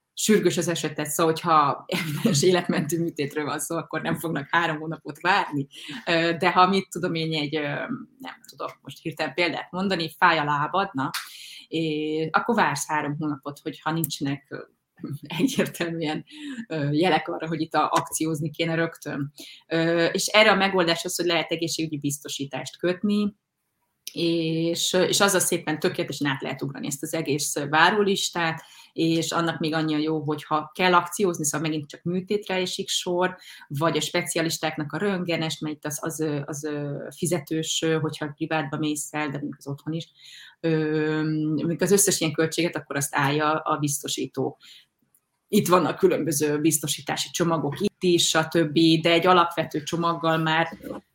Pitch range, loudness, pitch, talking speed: 155-175 Hz, -24 LUFS, 160 Hz, 150 wpm